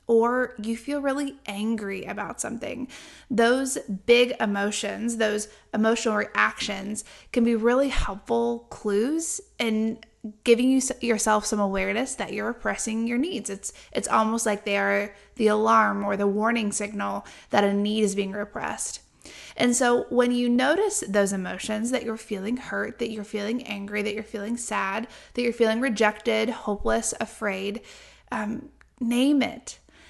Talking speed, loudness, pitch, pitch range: 150 wpm, -25 LUFS, 225 Hz, 210-245 Hz